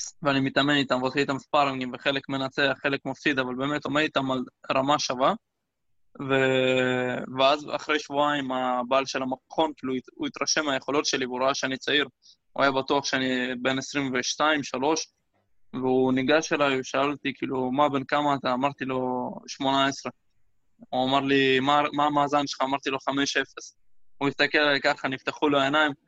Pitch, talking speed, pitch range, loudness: 135 Hz, 155 wpm, 130-145 Hz, -25 LUFS